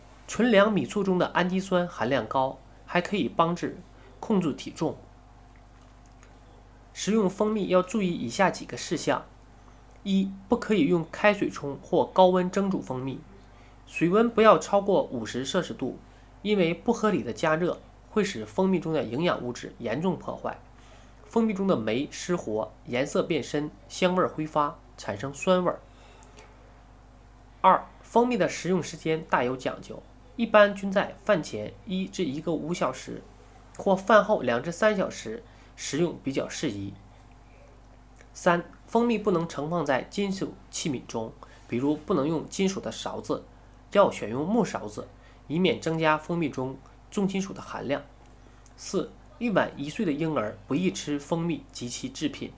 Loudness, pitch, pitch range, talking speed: -27 LUFS, 155 Hz, 120-190 Hz, 225 characters per minute